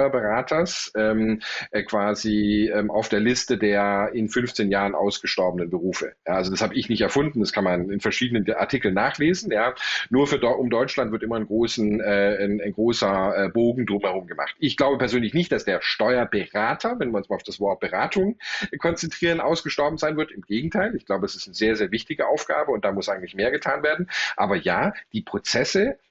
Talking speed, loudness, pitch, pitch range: 195 wpm, -23 LUFS, 110 Hz, 105-140 Hz